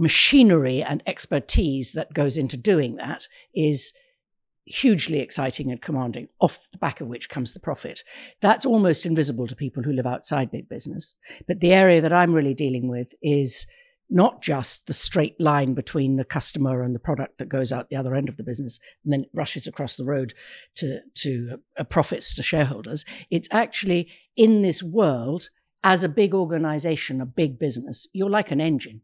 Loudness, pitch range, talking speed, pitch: -22 LUFS, 130-175 Hz, 185 wpm, 150 Hz